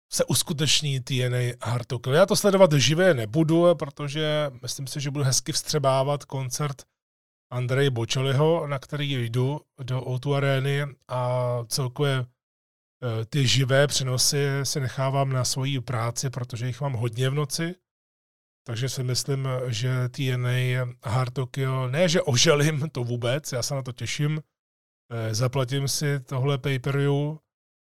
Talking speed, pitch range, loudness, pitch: 130 wpm, 125-145 Hz, -25 LUFS, 135 Hz